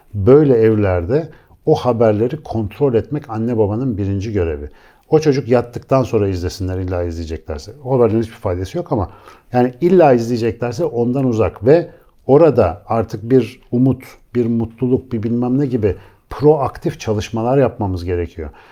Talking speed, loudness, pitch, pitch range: 140 wpm, -16 LUFS, 115 Hz, 100-130 Hz